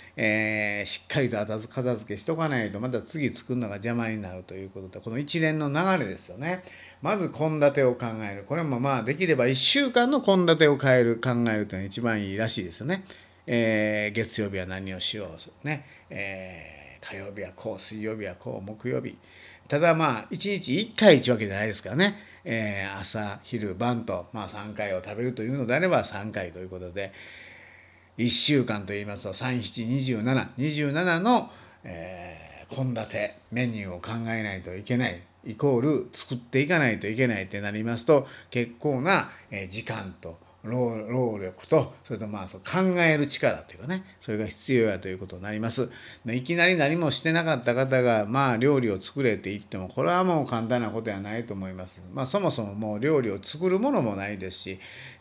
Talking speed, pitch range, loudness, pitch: 350 characters per minute, 100-140 Hz, -26 LUFS, 115 Hz